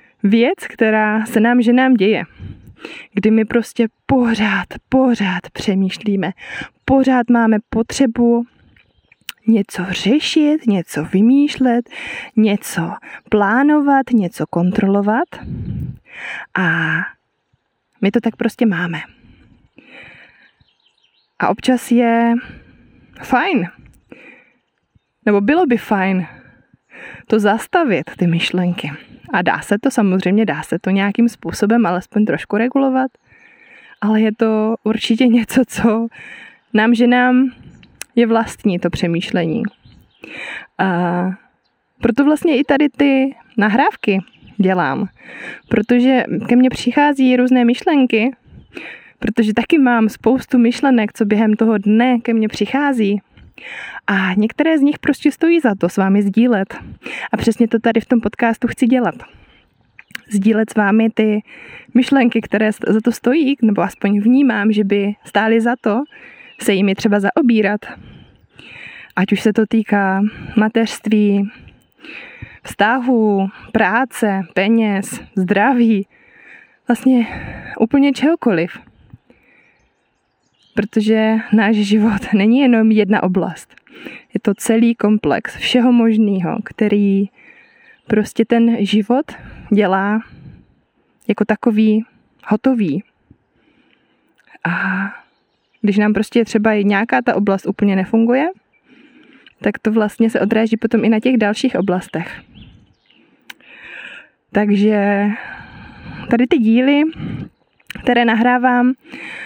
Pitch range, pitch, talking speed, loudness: 205-250 Hz, 225 Hz, 105 wpm, -16 LUFS